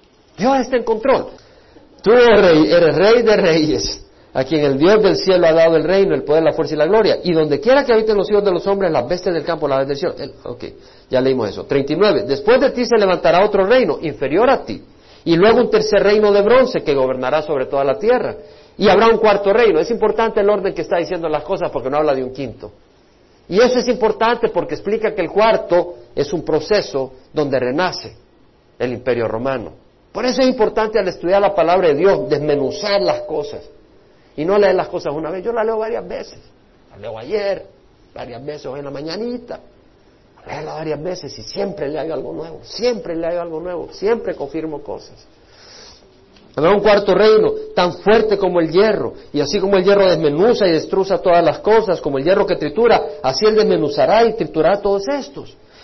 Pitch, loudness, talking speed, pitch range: 195 Hz, -16 LUFS, 210 wpm, 155-220 Hz